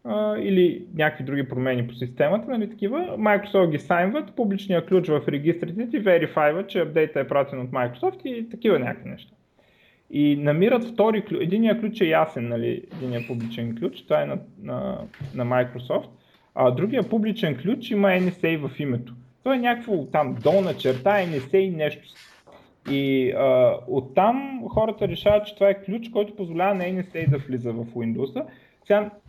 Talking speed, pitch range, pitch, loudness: 165 wpm, 140-210 Hz, 185 Hz, -23 LUFS